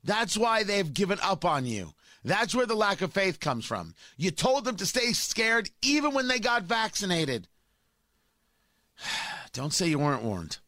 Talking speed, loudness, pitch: 175 wpm, -27 LUFS, 195 Hz